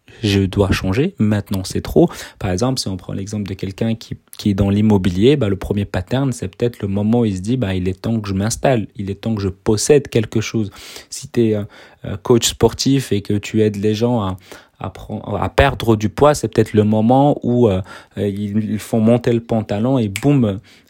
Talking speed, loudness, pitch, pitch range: 225 wpm, -17 LUFS, 110 Hz, 100-120 Hz